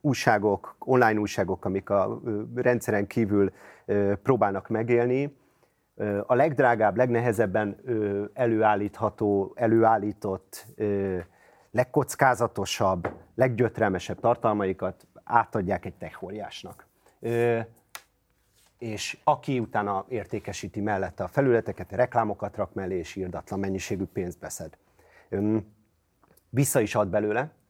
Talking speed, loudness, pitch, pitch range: 85 wpm, -26 LUFS, 105 Hz, 100-120 Hz